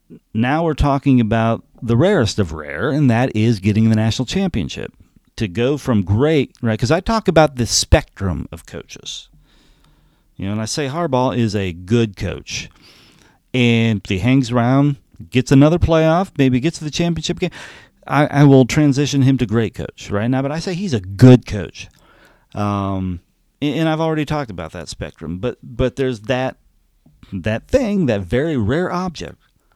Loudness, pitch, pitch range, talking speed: -17 LUFS, 125 Hz, 105-150 Hz, 175 wpm